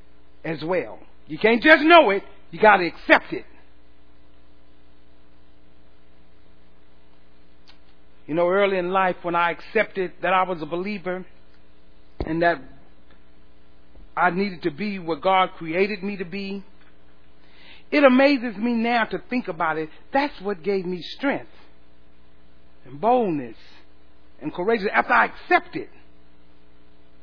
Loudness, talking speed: -21 LUFS, 130 wpm